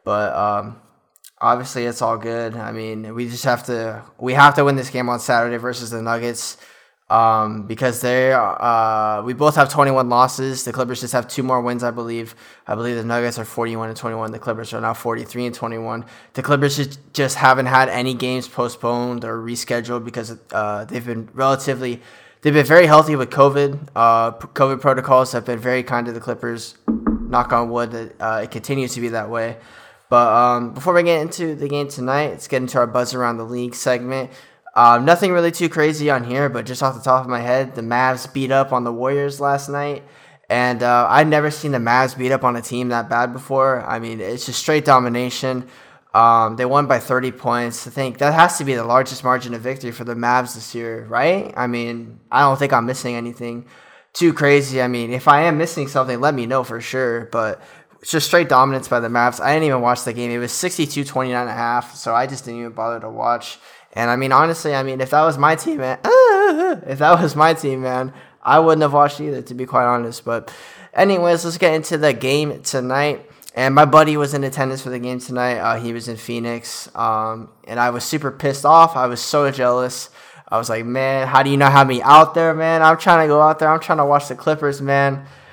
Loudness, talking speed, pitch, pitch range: -17 LUFS, 225 wpm, 125 Hz, 120-140 Hz